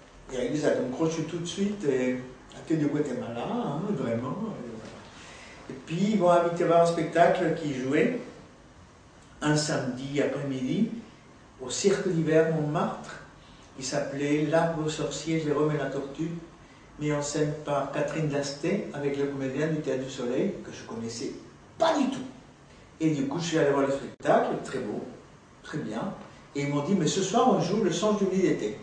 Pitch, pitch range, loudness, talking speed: 155 Hz, 140-175 Hz, -28 LUFS, 180 wpm